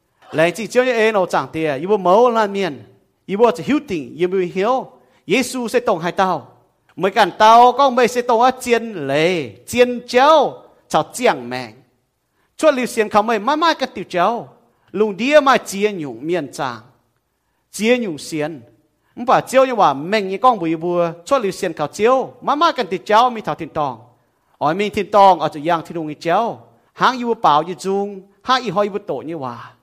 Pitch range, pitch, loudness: 160-235 Hz, 195 Hz, -17 LUFS